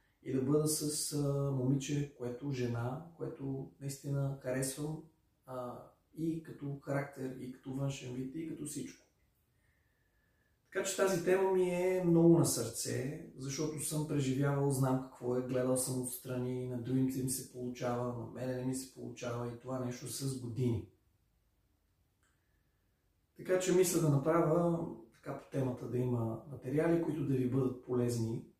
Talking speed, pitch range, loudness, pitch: 150 wpm, 125-150 Hz, -35 LUFS, 130 Hz